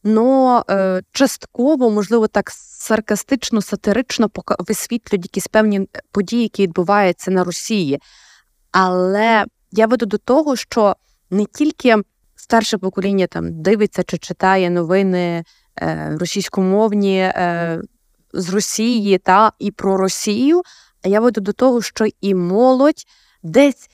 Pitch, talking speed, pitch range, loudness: 205 Hz, 120 wpm, 185-225 Hz, -17 LUFS